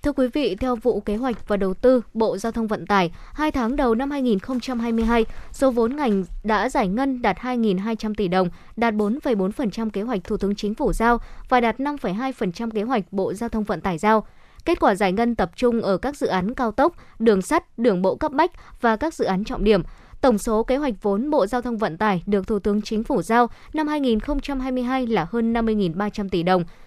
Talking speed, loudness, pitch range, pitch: 215 wpm, -22 LUFS, 205-255 Hz, 225 Hz